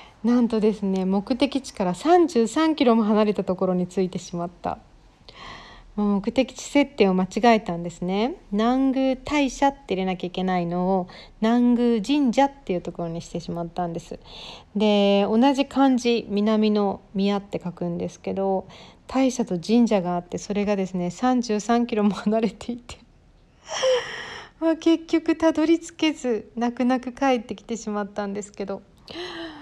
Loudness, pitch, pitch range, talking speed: -23 LUFS, 220 Hz, 190-265 Hz, 295 characters per minute